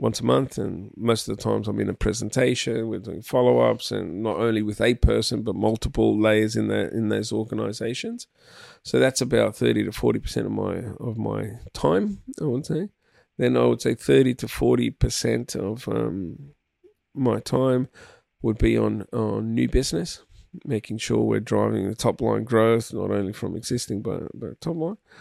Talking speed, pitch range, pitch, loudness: 190 wpm, 105-125 Hz, 115 Hz, -24 LUFS